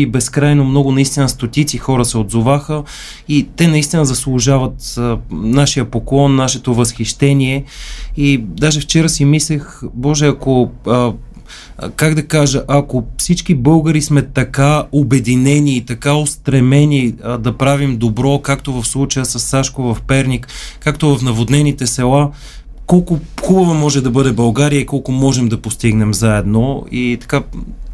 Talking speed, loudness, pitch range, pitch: 140 wpm, -13 LUFS, 125-145 Hz, 135 Hz